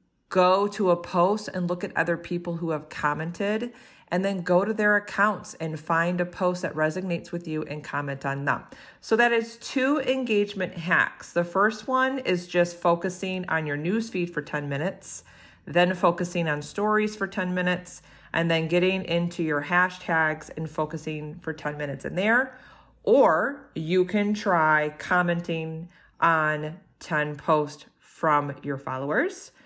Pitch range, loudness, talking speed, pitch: 155-195 Hz, -26 LUFS, 160 wpm, 175 Hz